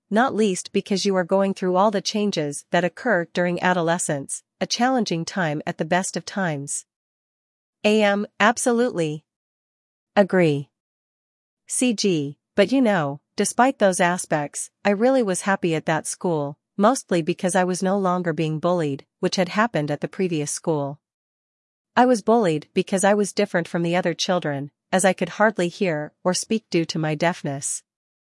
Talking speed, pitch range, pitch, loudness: 160 wpm, 160-200 Hz, 180 Hz, -22 LUFS